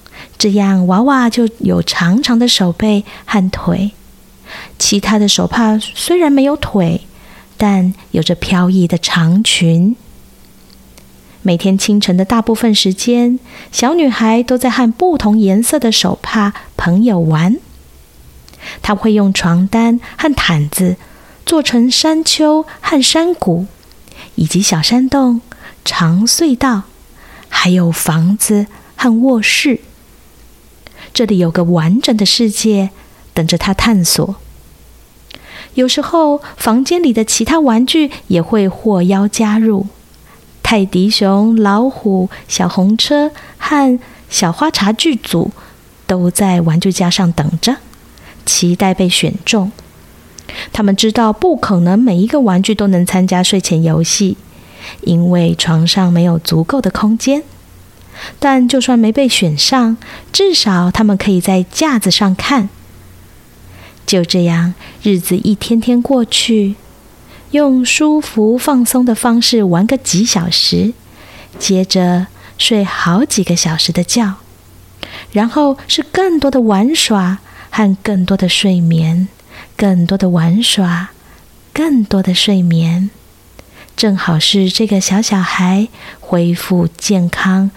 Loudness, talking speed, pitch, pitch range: -12 LUFS, 180 characters per minute, 200 Hz, 180-235 Hz